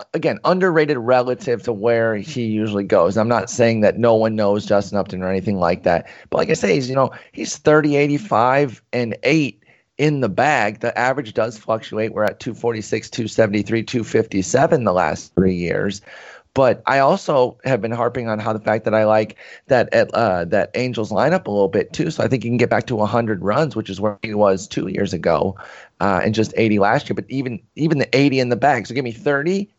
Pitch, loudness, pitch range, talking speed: 115 Hz, -19 LUFS, 105-125 Hz, 220 wpm